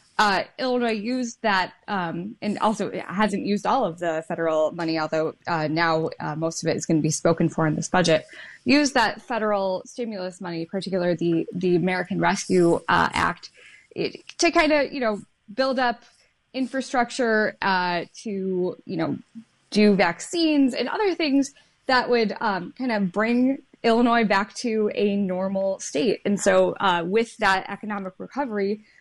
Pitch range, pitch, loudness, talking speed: 180-245 Hz, 205 Hz, -23 LUFS, 165 wpm